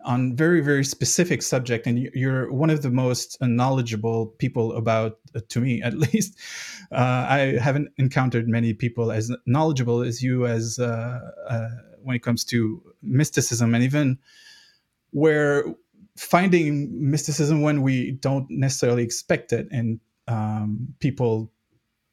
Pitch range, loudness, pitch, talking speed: 115-145 Hz, -23 LUFS, 125 Hz, 135 wpm